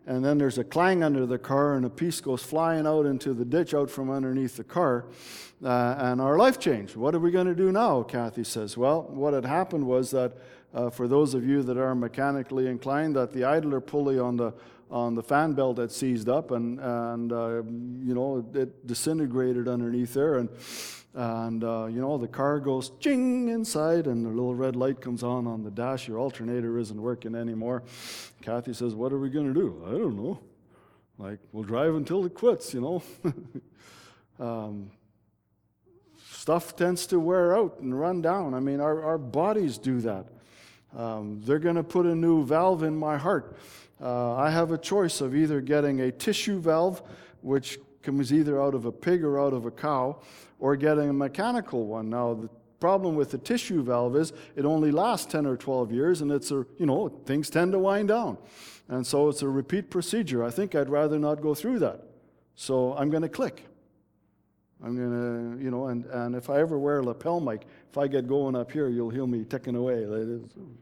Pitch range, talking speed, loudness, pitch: 120-155 Hz, 205 wpm, -27 LUFS, 135 Hz